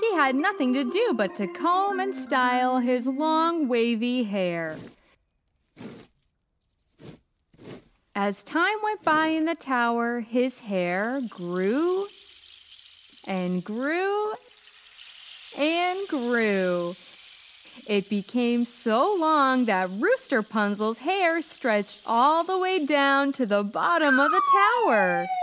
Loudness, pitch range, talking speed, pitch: -24 LUFS, 215-345 Hz, 110 wpm, 260 Hz